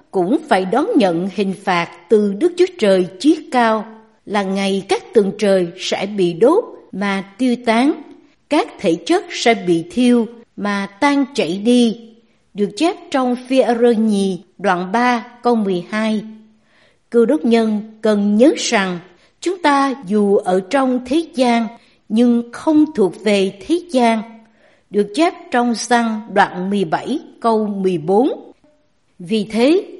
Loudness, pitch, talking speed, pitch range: -17 LUFS, 225 Hz, 145 wpm, 200-265 Hz